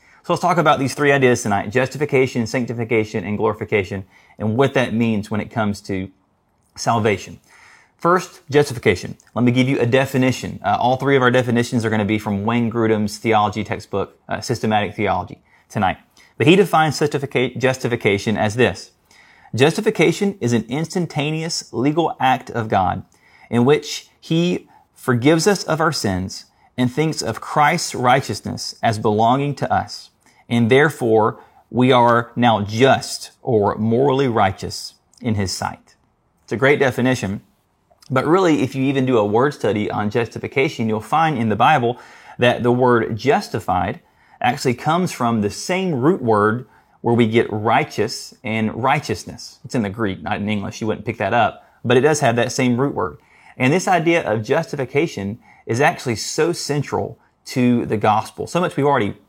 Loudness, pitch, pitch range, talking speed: -19 LUFS, 120 Hz, 110-140 Hz, 165 wpm